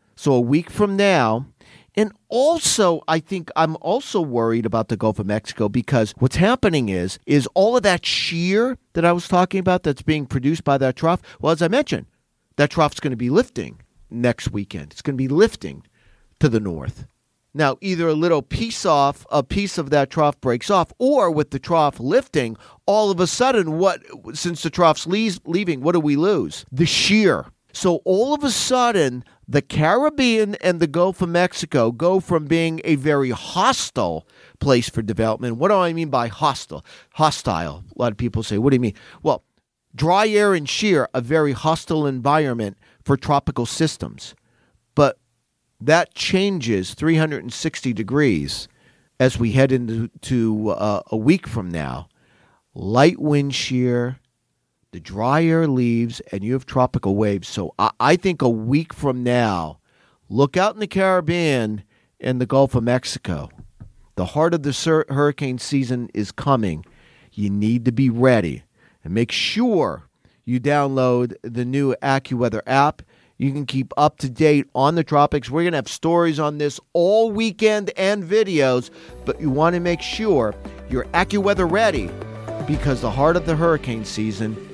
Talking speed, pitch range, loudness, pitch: 170 wpm, 115-170 Hz, -20 LUFS, 140 Hz